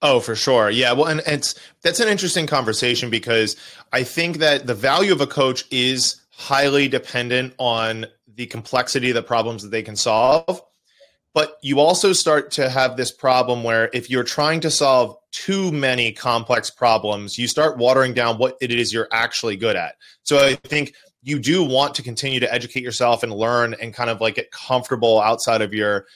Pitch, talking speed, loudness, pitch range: 125 Hz, 195 wpm, -19 LUFS, 115-145 Hz